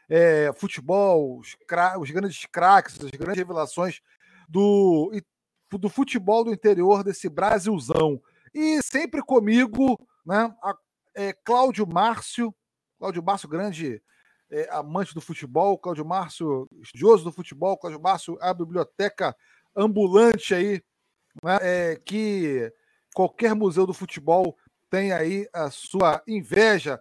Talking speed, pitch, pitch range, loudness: 120 wpm, 195 Hz, 170-215 Hz, -23 LUFS